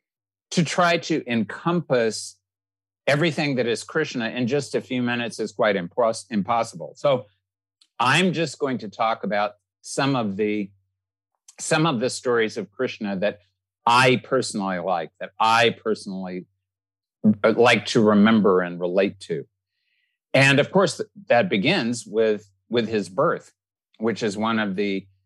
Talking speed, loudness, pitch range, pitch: 145 wpm, -22 LUFS, 95-135 Hz, 110 Hz